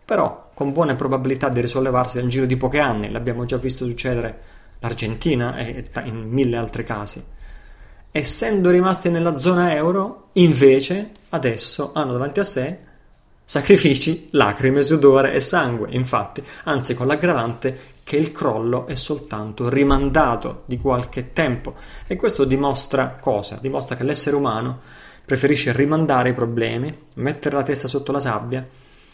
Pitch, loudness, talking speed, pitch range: 130 Hz, -20 LUFS, 140 wpm, 120-145 Hz